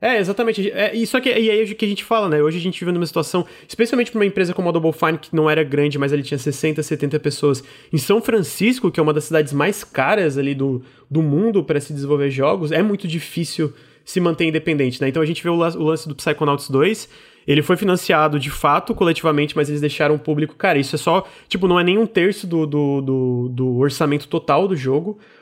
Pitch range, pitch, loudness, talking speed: 145-190 Hz, 160 Hz, -19 LUFS, 245 wpm